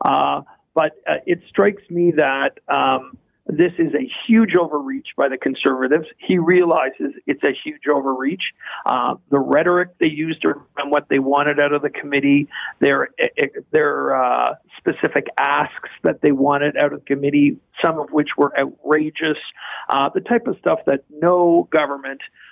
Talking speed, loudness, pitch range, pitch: 160 wpm, -19 LUFS, 145-190 Hz, 155 Hz